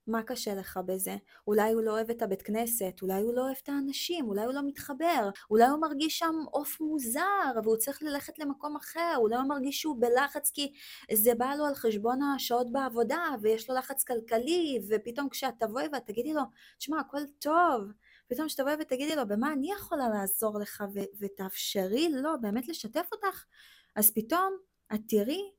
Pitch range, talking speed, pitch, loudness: 220-295 Hz, 185 wpm, 265 Hz, -31 LUFS